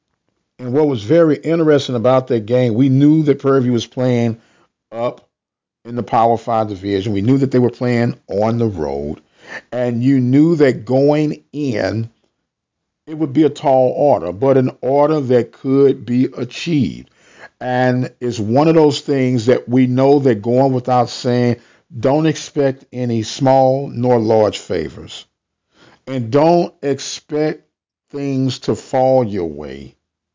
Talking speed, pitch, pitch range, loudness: 150 wpm, 130 Hz, 120-140 Hz, -16 LUFS